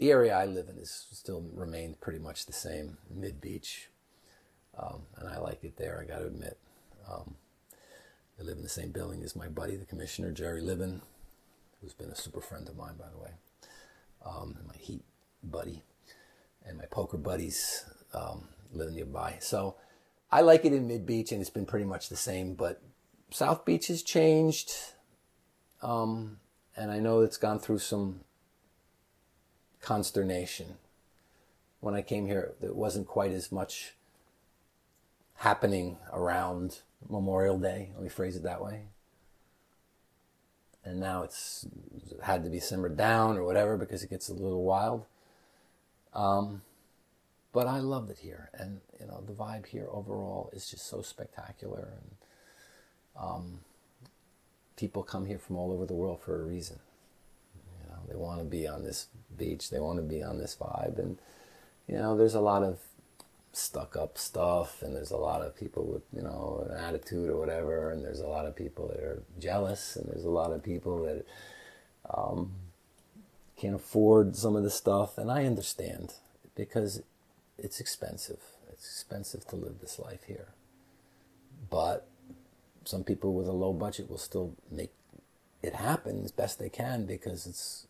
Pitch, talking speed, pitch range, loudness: 95 Hz, 165 wpm, 90-110 Hz, -33 LUFS